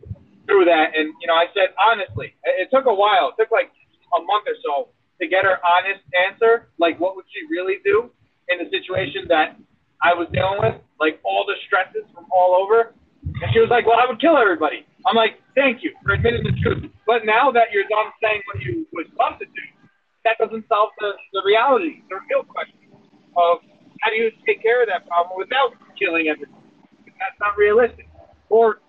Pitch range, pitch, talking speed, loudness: 185-275 Hz, 220 Hz, 205 wpm, -19 LUFS